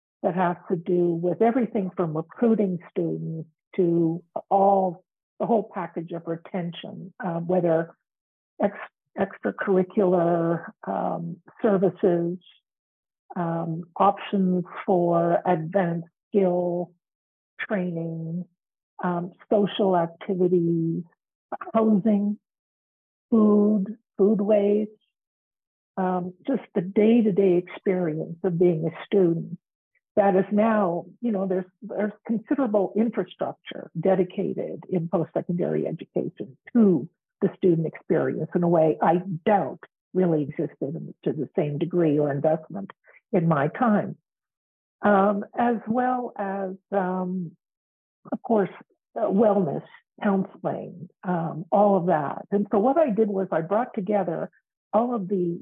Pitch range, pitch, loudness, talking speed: 170-205 Hz, 185 Hz, -25 LUFS, 115 wpm